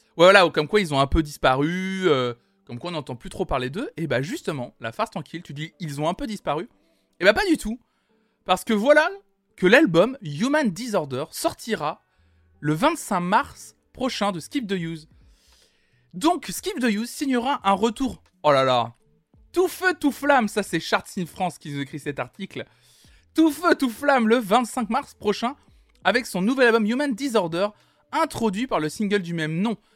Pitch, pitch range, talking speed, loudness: 210 Hz, 160-255 Hz, 190 wpm, -23 LUFS